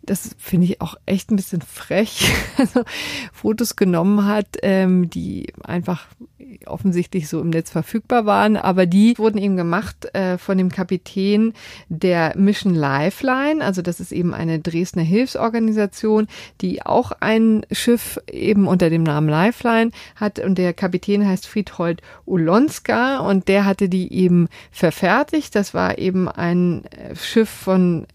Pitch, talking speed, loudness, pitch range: 195 Hz, 140 wpm, -19 LUFS, 175-215 Hz